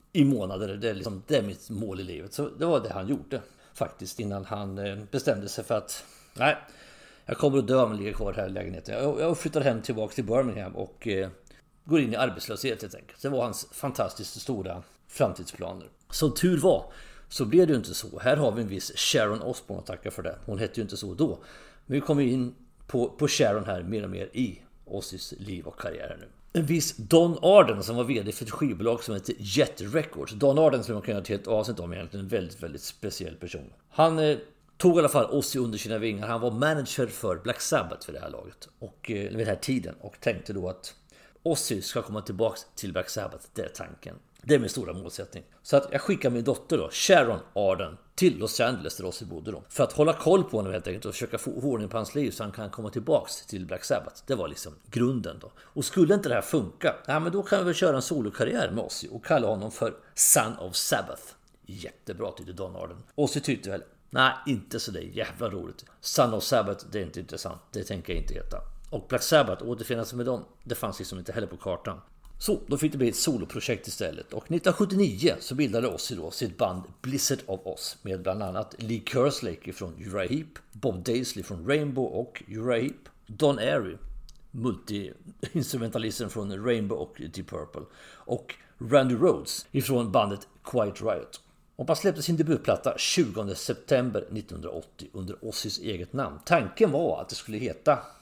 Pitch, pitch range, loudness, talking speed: 115 Hz, 100-140 Hz, -28 LUFS, 210 wpm